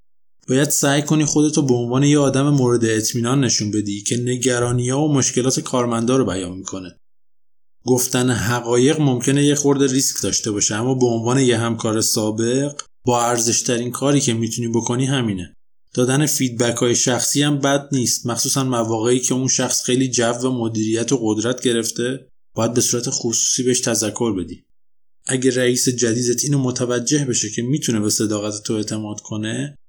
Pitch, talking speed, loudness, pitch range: 125 Hz, 165 wpm, -18 LUFS, 115-130 Hz